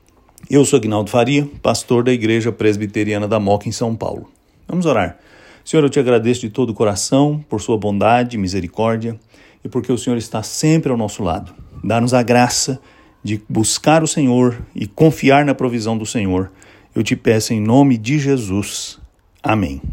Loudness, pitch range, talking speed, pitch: -16 LUFS, 105-130 Hz, 175 wpm, 115 Hz